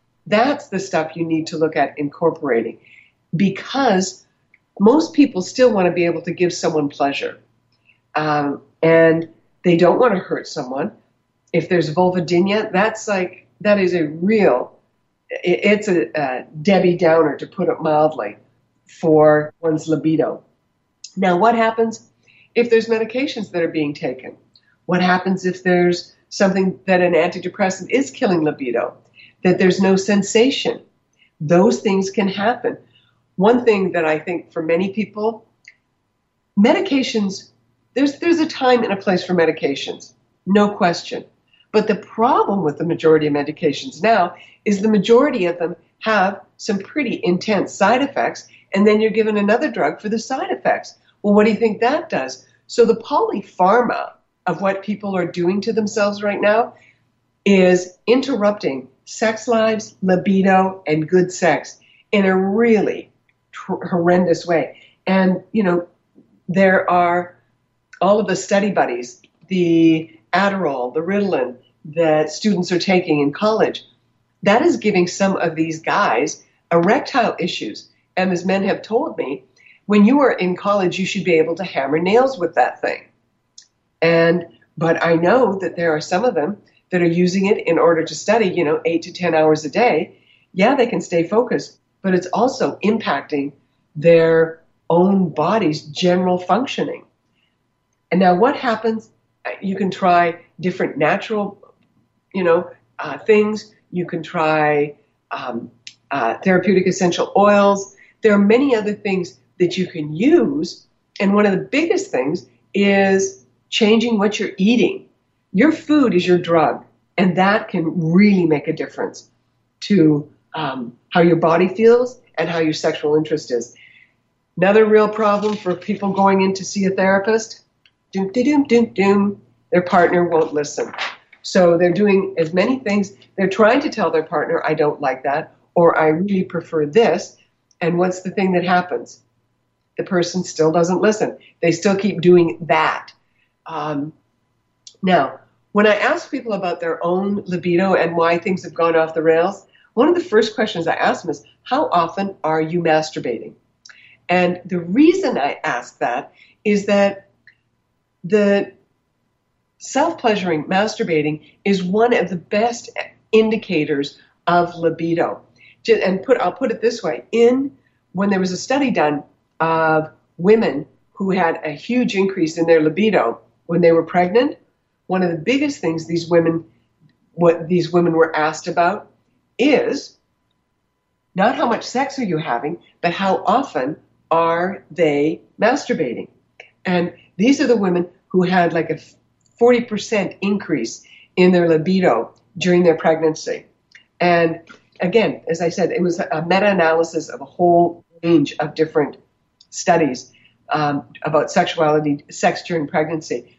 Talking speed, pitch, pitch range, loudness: 150 wpm, 180 Hz, 160-205 Hz, -18 LUFS